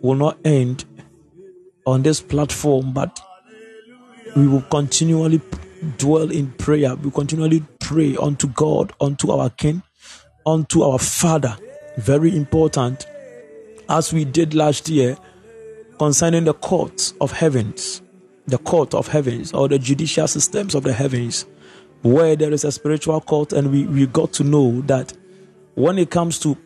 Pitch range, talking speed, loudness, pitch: 140-165 Hz, 145 wpm, -18 LUFS, 155 Hz